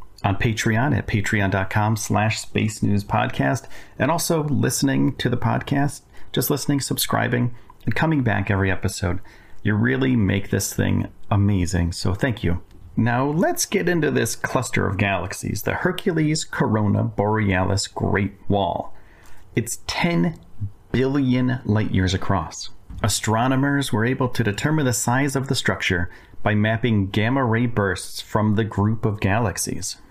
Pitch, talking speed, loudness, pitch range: 110 Hz, 135 wpm, -22 LUFS, 100-130 Hz